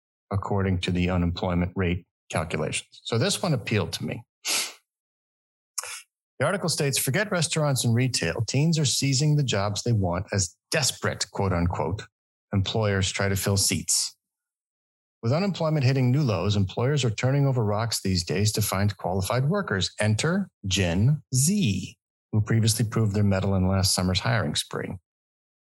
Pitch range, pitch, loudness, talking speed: 95-130 Hz, 105 Hz, -25 LUFS, 150 wpm